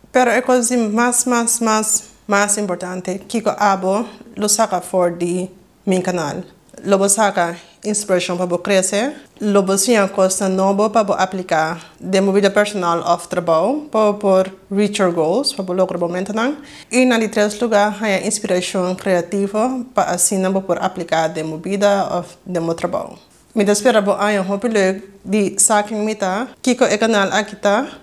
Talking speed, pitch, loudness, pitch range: 135 wpm, 200 Hz, -17 LUFS, 185-215 Hz